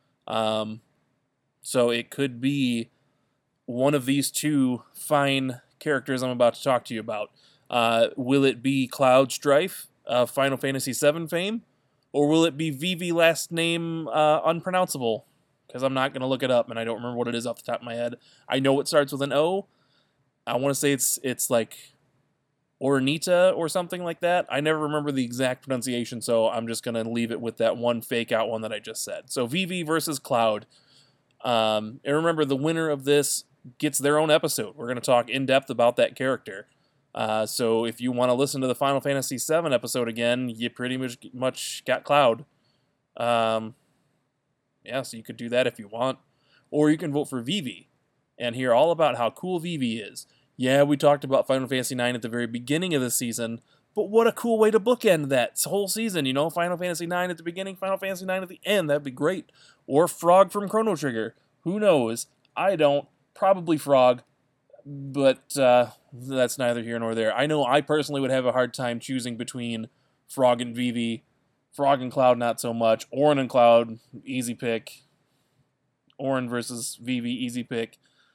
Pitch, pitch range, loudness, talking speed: 135 Hz, 120-150 Hz, -25 LUFS, 200 wpm